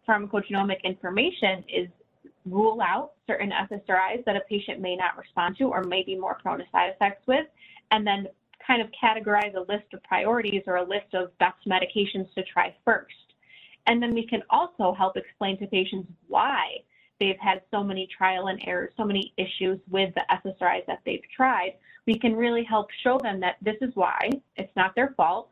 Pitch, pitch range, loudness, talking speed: 200 Hz, 185-225 Hz, -26 LUFS, 190 wpm